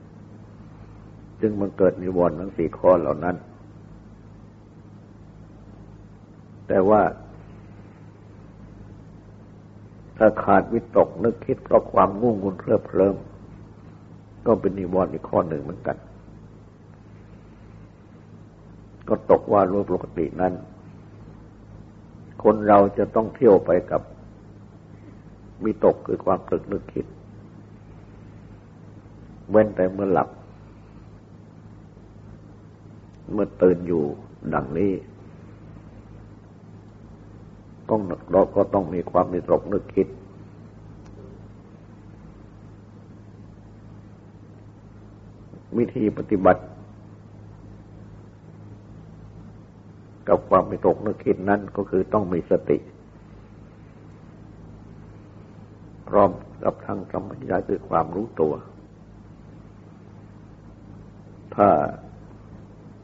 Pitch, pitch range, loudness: 100 Hz, 95-105 Hz, -22 LUFS